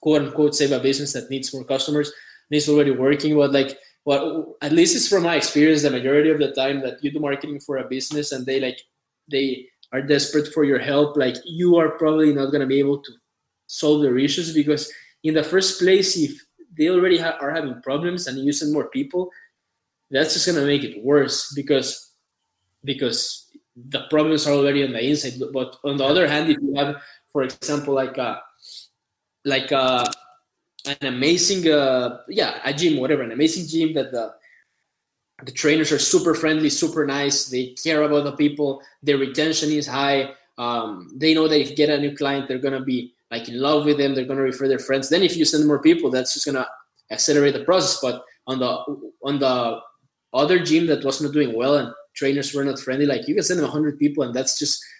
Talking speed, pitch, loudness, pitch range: 210 wpm, 145 Hz, -20 LUFS, 135-155 Hz